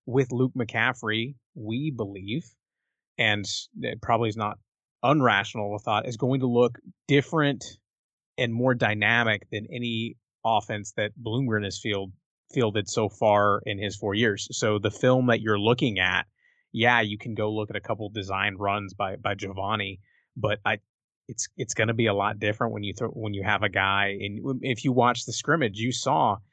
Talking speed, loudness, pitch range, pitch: 185 wpm, -26 LUFS, 105-120 Hz, 110 Hz